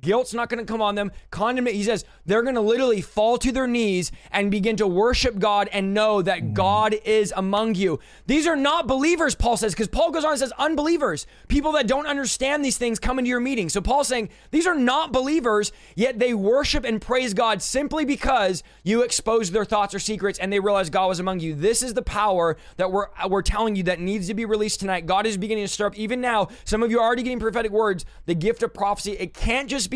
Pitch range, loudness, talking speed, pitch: 200-250 Hz, -22 LUFS, 240 wpm, 220 Hz